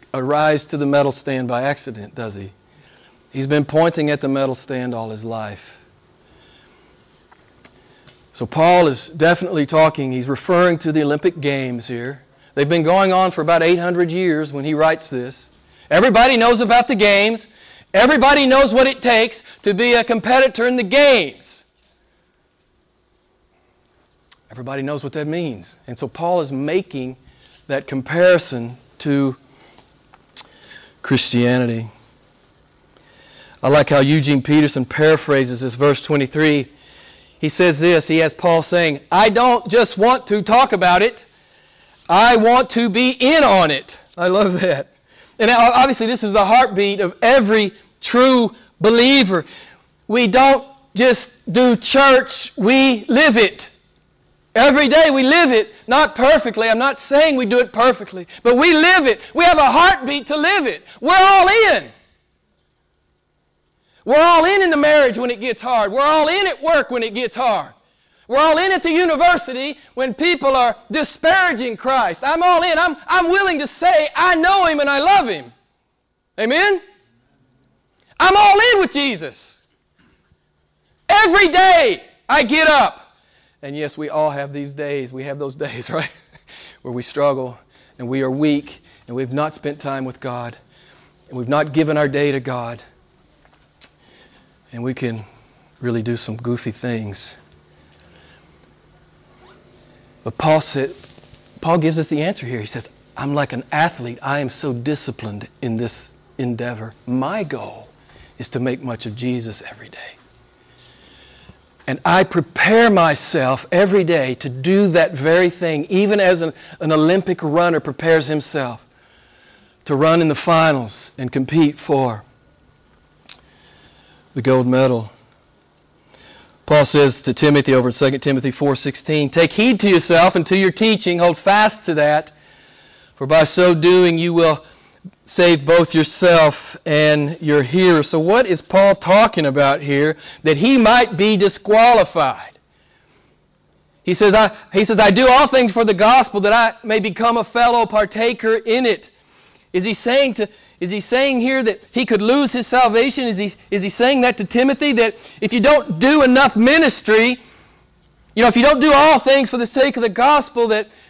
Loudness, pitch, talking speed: -15 LUFS, 175 Hz, 160 wpm